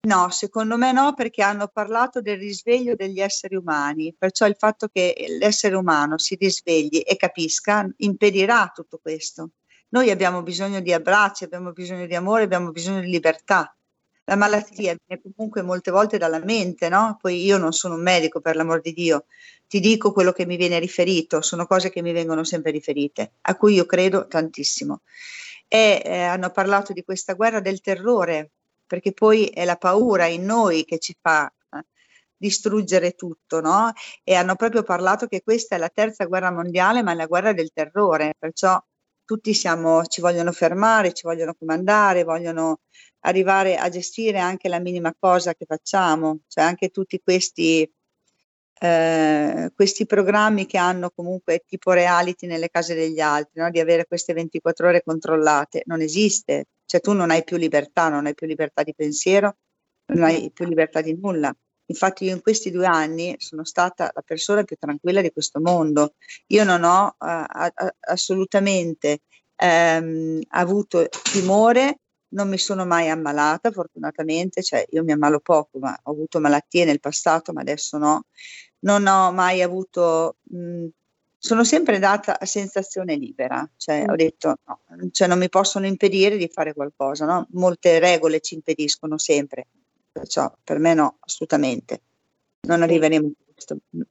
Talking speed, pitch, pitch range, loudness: 165 wpm, 180 Hz, 160-200 Hz, -20 LUFS